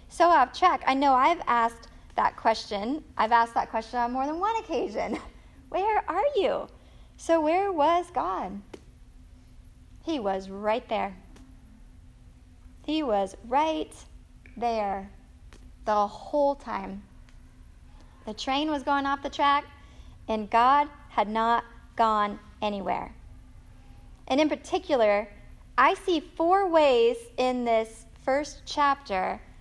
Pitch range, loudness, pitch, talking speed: 210-305 Hz, -26 LUFS, 250 Hz, 120 wpm